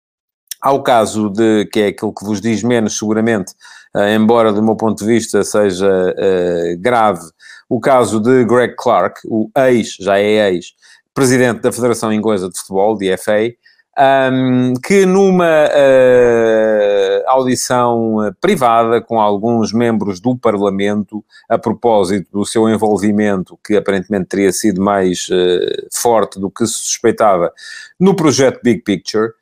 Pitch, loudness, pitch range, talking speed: 110 Hz, -13 LUFS, 105-125 Hz, 145 wpm